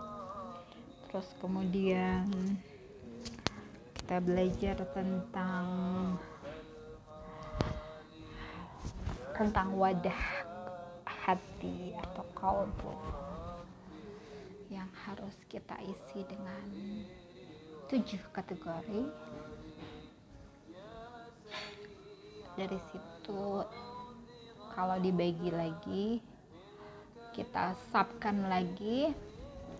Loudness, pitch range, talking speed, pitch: -38 LUFS, 180-205 Hz, 50 wpm, 190 Hz